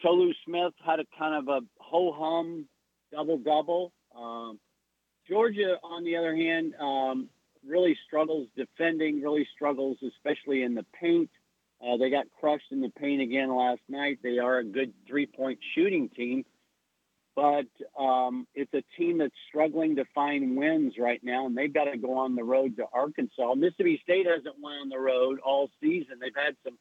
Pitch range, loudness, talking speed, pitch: 130-170 Hz, -29 LUFS, 170 wpm, 145 Hz